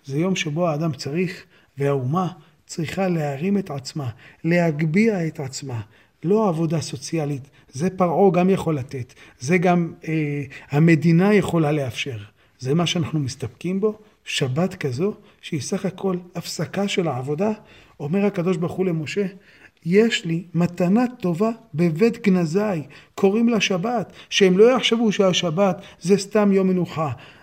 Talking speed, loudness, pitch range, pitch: 135 wpm, -21 LUFS, 150-195 Hz, 175 Hz